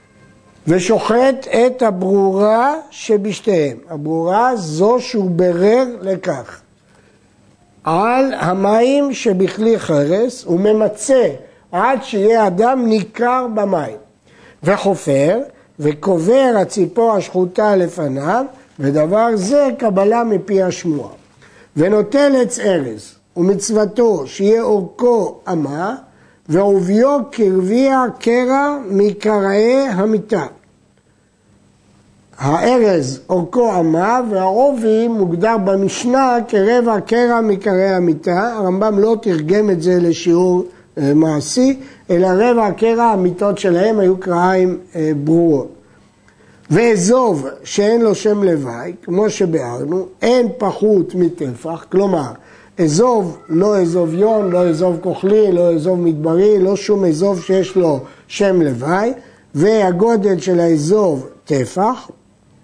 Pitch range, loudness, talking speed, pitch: 175-225 Hz, -15 LUFS, 95 wpm, 195 Hz